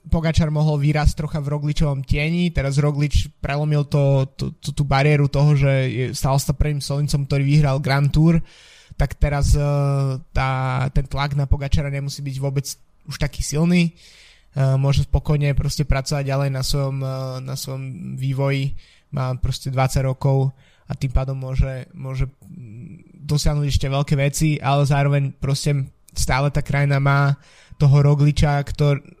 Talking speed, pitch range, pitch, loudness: 145 wpm, 135-150 Hz, 140 Hz, -20 LUFS